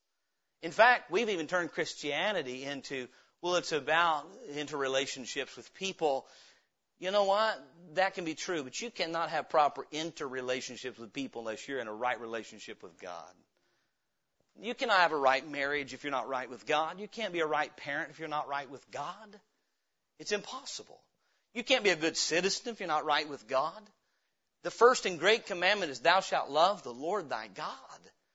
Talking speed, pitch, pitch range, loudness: 185 wpm, 150 Hz, 135-190 Hz, -32 LUFS